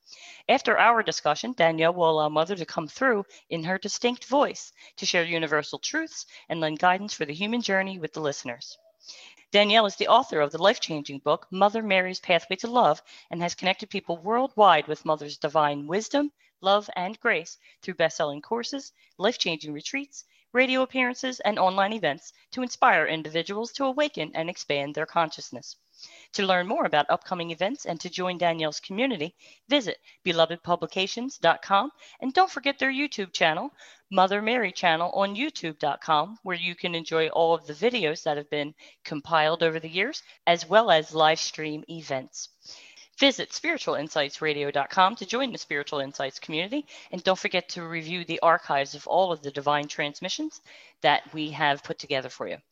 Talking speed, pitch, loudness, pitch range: 165 wpm, 180 Hz, -26 LUFS, 155-230 Hz